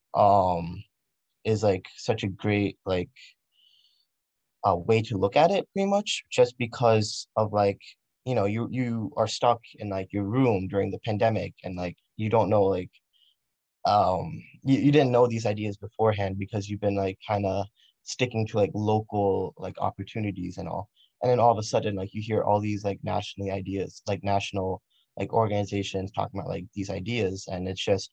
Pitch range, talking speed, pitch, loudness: 95-110 Hz, 185 wpm, 105 Hz, -27 LUFS